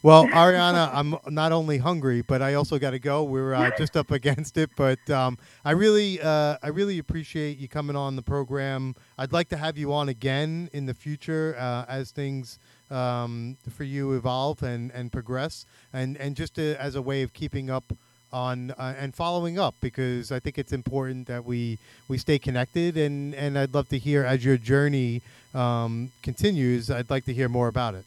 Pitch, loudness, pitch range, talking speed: 135 Hz, -26 LUFS, 125-150 Hz, 200 wpm